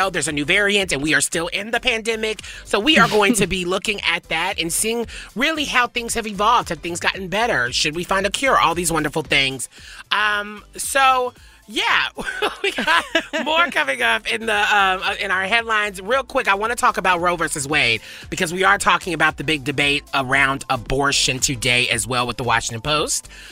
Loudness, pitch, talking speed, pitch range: -18 LUFS, 190 Hz, 205 wpm, 150-225 Hz